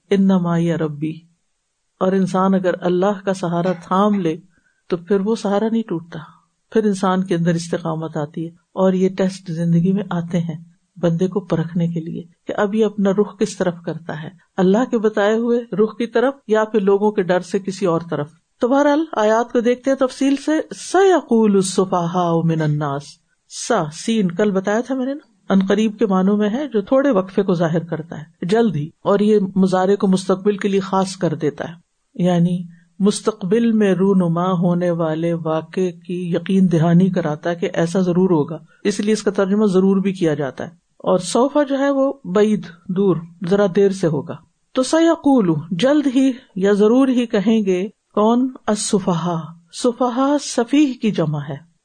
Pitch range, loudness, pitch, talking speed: 170-215 Hz, -18 LUFS, 190 Hz, 180 wpm